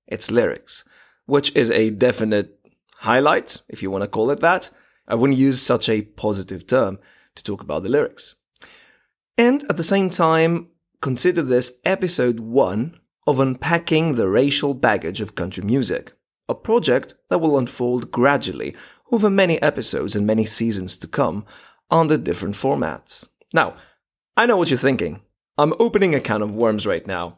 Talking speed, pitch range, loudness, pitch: 160 wpm, 110-165 Hz, -19 LUFS, 135 Hz